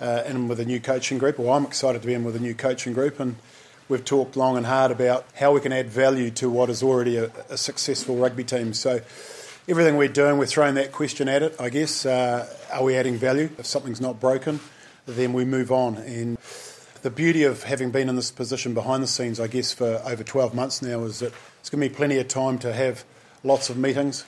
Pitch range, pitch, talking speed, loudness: 125-140 Hz, 130 Hz, 255 wpm, -24 LUFS